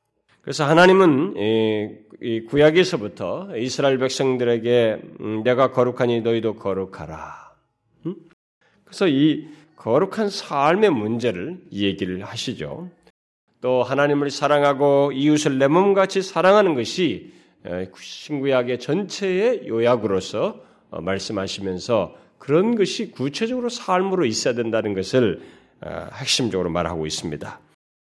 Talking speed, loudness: 270 characters per minute, -20 LUFS